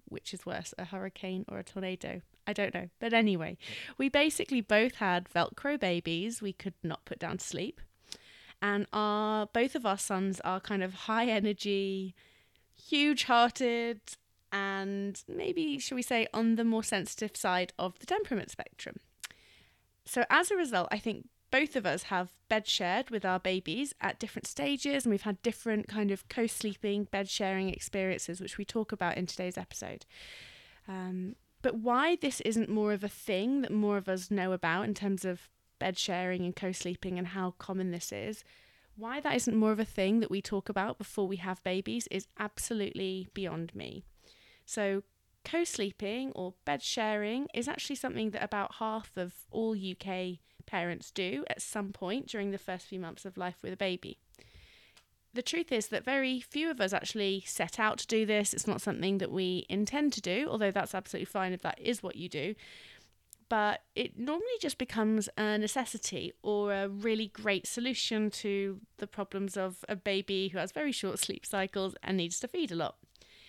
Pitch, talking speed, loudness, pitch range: 205 Hz, 185 wpm, -33 LUFS, 185-230 Hz